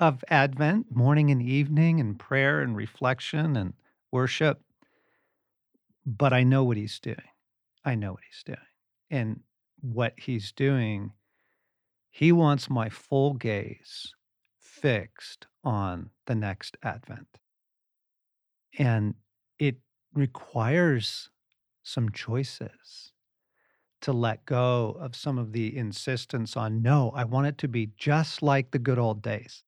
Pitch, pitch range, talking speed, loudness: 125 Hz, 115-140 Hz, 125 wpm, -27 LUFS